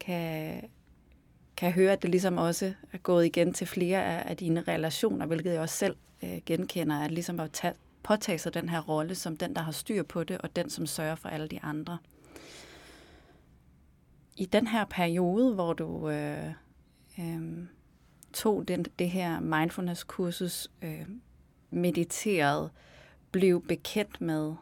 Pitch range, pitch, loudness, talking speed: 160-185 Hz, 170 Hz, -31 LUFS, 150 wpm